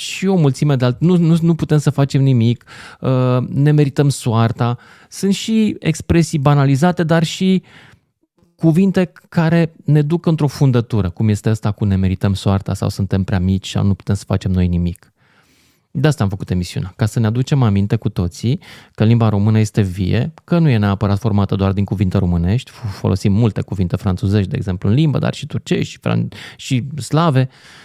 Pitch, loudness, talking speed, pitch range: 120 Hz, -16 LUFS, 185 wpm, 100-150 Hz